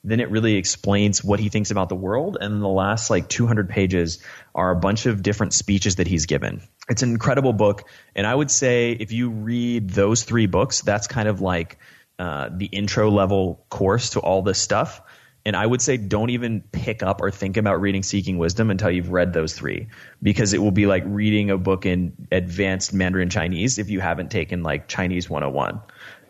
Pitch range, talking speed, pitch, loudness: 95-110 Hz, 205 wpm, 100 Hz, -21 LUFS